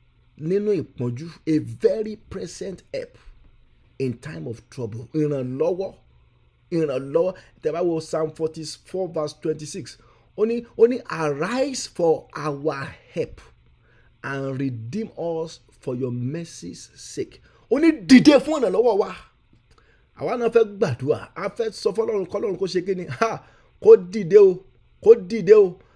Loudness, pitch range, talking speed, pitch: -22 LUFS, 135-225 Hz, 125 wpm, 165 Hz